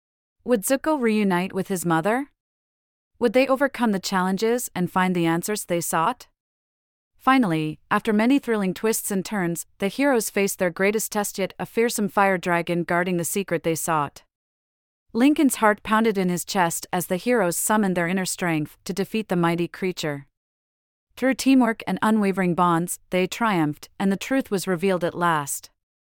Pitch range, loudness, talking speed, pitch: 170-220 Hz, -23 LUFS, 165 wpm, 190 Hz